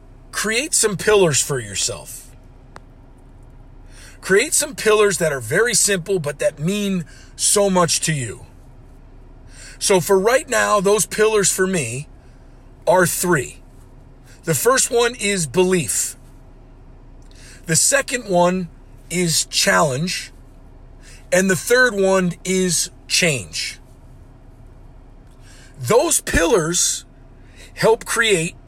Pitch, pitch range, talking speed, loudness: 165 Hz, 130-195 Hz, 105 wpm, -17 LUFS